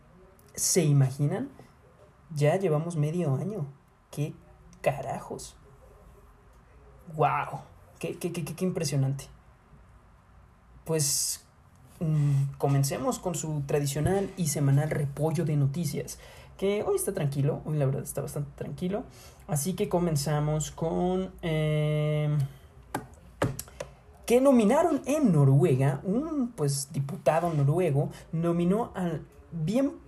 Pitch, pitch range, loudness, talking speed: 155 Hz, 145-180 Hz, -28 LUFS, 105 wpm